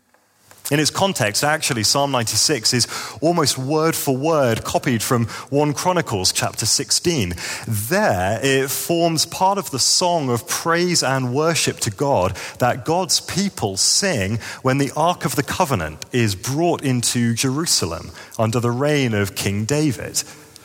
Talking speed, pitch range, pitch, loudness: 145 wpm, 115-155 Hz, 135 Hz, -19 LUFS